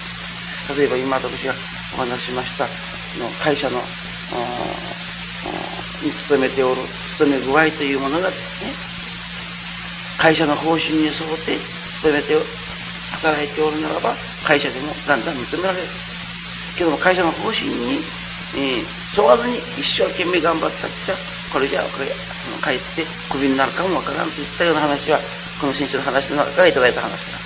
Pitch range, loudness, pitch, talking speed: 145-175 Hz, -20 LUFS, 160 Hz, 310 characters per minute